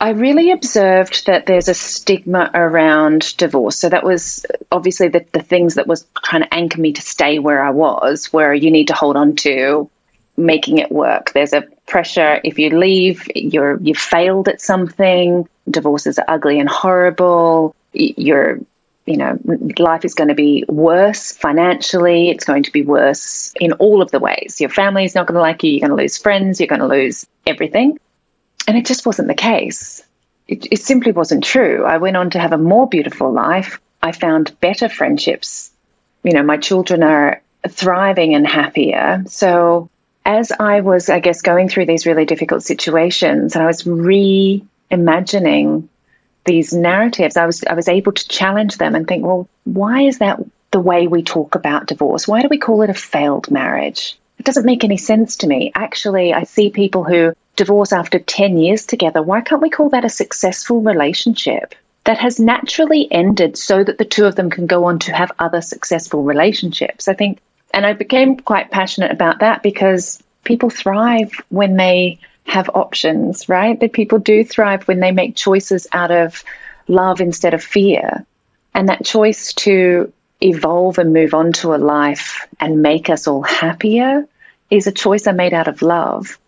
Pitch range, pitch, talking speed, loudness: 165-205 Hz, 180 Hz, 185 wpm, -14 LUFS